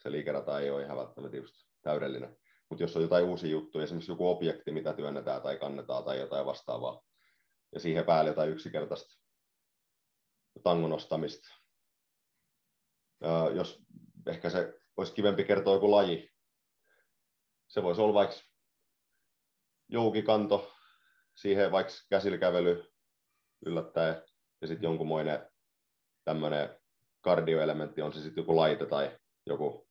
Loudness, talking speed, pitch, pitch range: -32 LUFS, 120 wpm, 80 Hz, 75-100 Hz